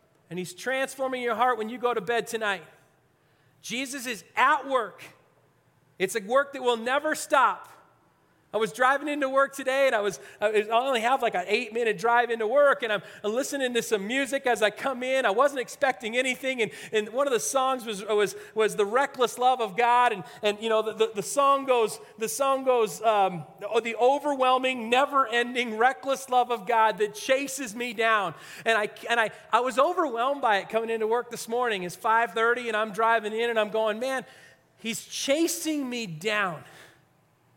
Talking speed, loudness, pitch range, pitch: 195 wpm, -26 LUFS, 215-260 Hz, 235 Hz